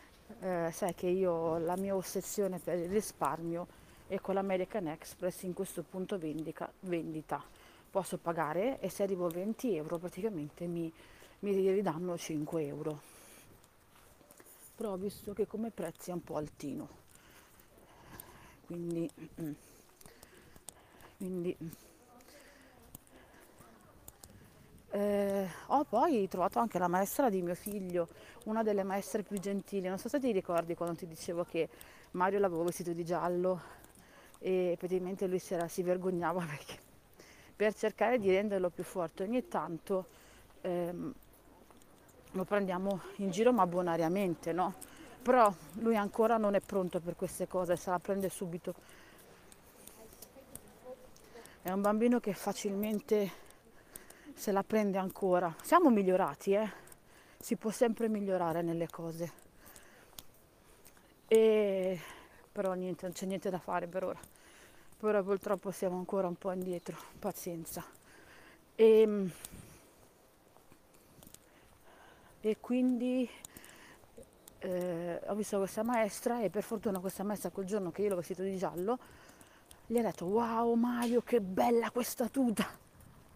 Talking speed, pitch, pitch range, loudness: 125 wpm, 190 Hz, 175-210 Hz, -35 LUFS